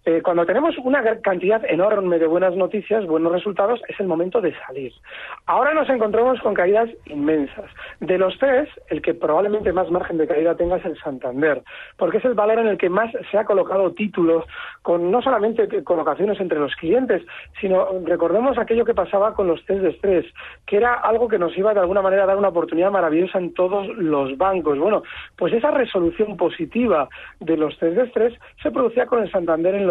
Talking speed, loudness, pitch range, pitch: 195 wpm, -20 LUFS, 175-225 Hz, 195 Hz